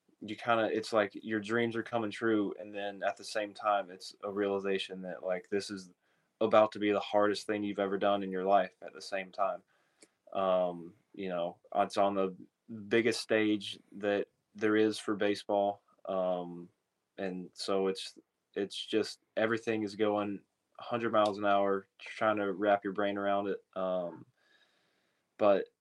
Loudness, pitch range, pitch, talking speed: -33 LUFS, 95-105 Hz, 100 Hz, 170 wpm